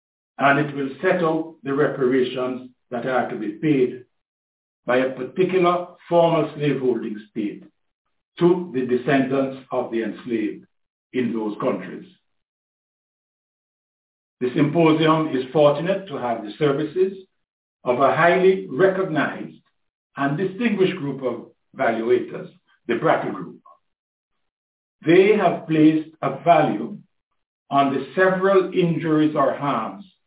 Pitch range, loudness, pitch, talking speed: 130-175 Hz, -21 LUFS, 150 Hz, 115 wpm